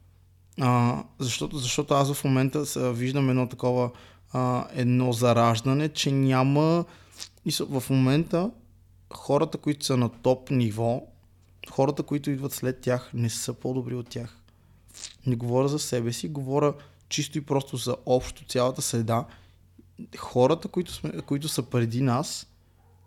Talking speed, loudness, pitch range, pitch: 140 wpm, -26 LUFS, 115-140 Hz, 125 Hz